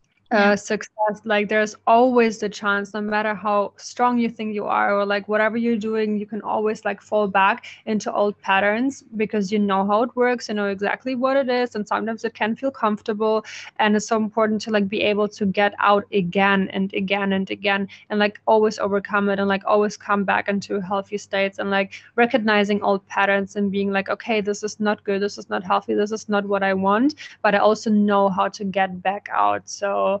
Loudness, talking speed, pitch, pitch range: -21 LUFS, 215 wpm, 210 Hz, 200-215 Hz